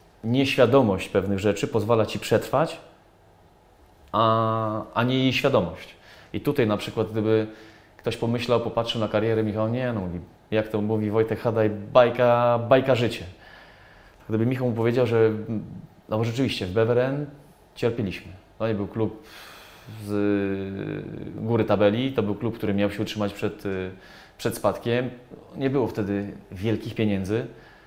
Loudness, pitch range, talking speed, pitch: -24 LUFS, 100-115 Hz, 140 wpm, 110 Hz